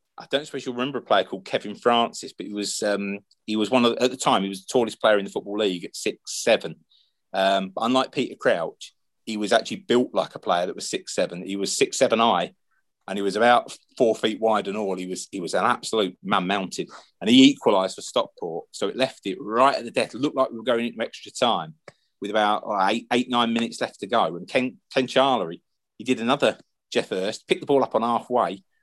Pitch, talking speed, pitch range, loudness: 115 Hz, 250 wpm, 100-130 Hz, -24 LUFS